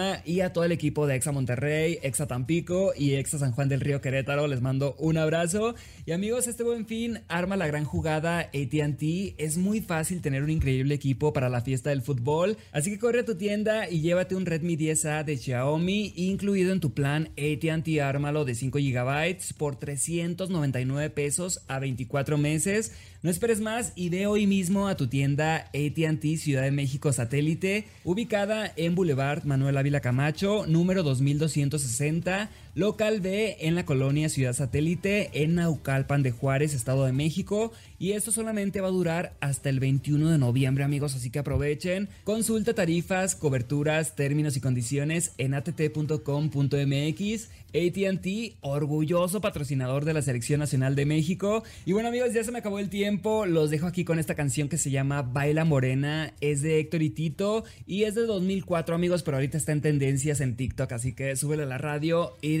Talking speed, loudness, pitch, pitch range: 175 wpm, -27 LUFS, 155 Hz, 140-185 Hz